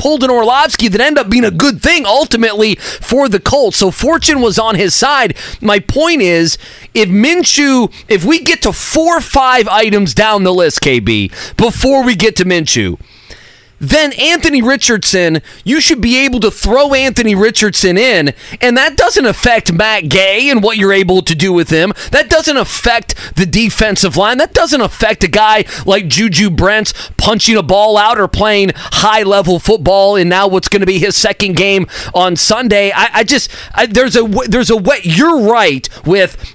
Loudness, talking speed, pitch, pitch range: -10 LUFS, 185 wpm, 215 Hz, 190-250 Hz